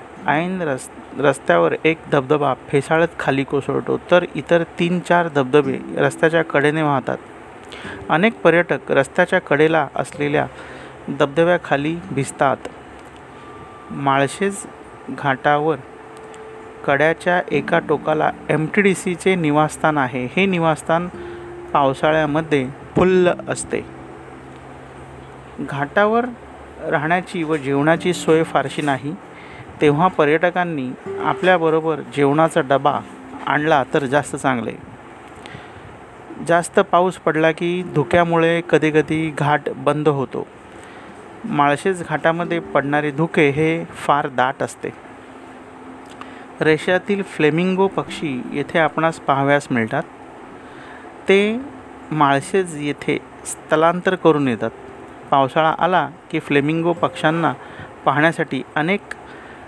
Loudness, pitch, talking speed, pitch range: -18 LUFS, 160 Hz, 90 wpm, 145-175 Hz